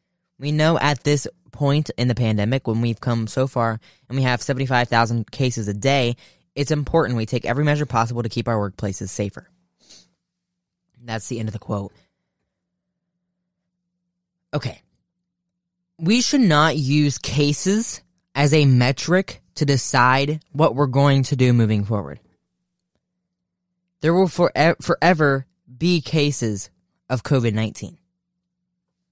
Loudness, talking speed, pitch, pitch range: -20 LUFS, 135 wpm, 145 Hz, 120-175 Hz